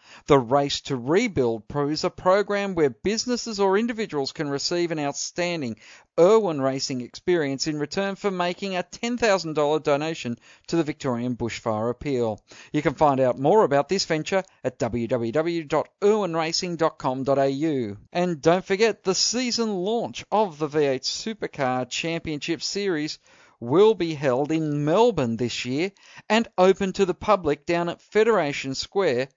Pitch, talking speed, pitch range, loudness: 160 Hz, 140 wpm, 135-195 Hz, -24 LUFS